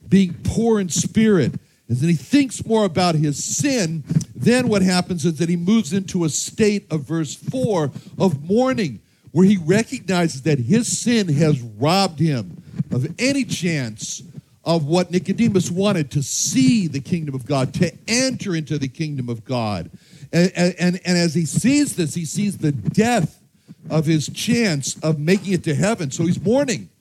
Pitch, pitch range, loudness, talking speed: 175 Hz, 155-200 Hz, -20 LUFS, 175 wpm